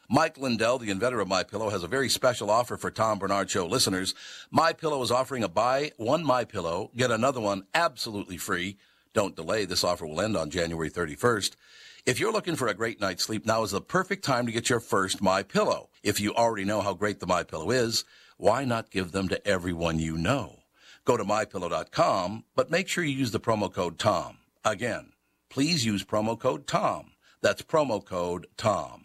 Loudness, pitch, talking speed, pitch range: -28 LUFS, 105 Hz, 195 wpm, 95-115 Hz